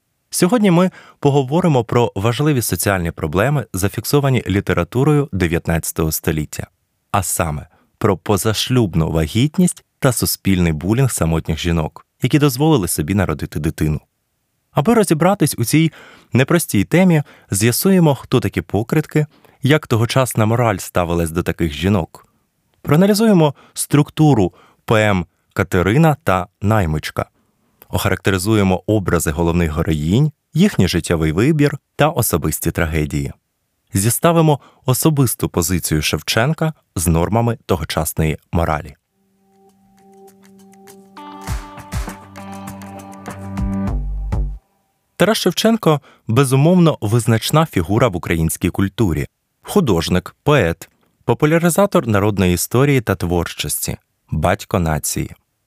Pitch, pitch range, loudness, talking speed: 110 Hz, 90-145 Hz, -17 LUFS, 90 wpm